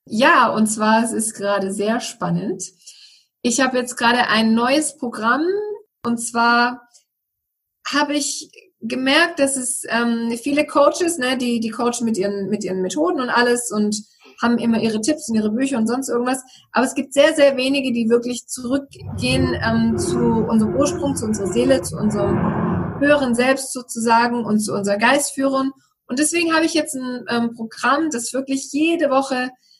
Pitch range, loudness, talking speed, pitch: 220-275 Hz, -19 LUFS, 170 wpm, 240 Hz